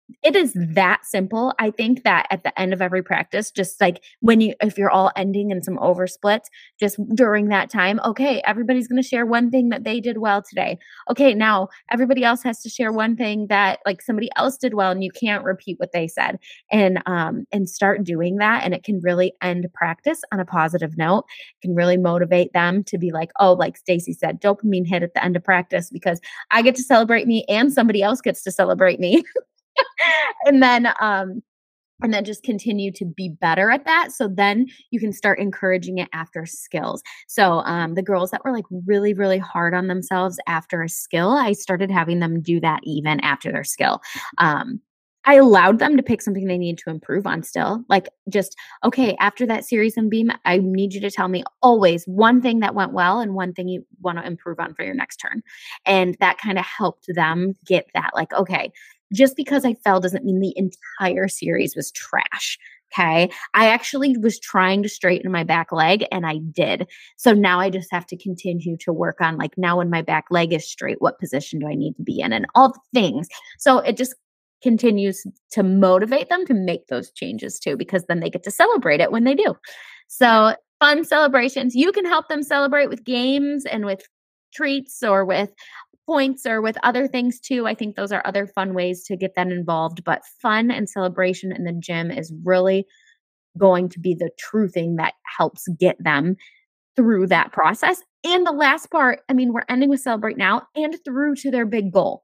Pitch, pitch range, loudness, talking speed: 200 Hz, 180-245 Hz, -19 LUFS, 210 wpm